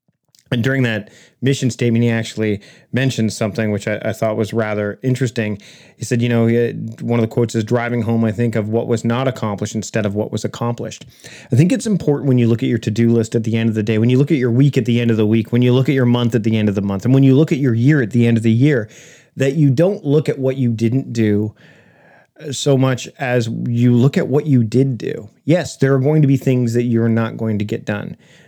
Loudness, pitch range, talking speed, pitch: -17 LUFS, 115-130 Hz, 270 wpm, 120 Hz